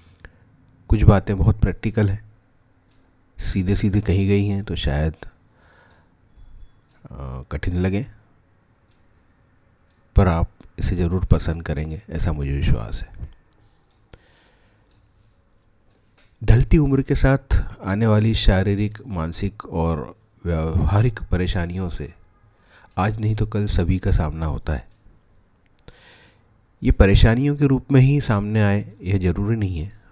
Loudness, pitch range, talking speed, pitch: -21 LUFS, 90-110 Hz, 115 wpm, 100 Hz